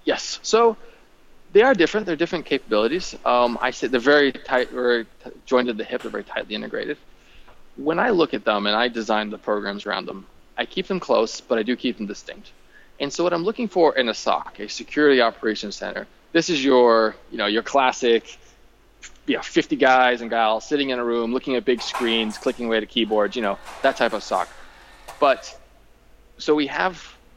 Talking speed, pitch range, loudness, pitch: 205 wpm, 110-145 Hz, -21 LUFS, 125 Hz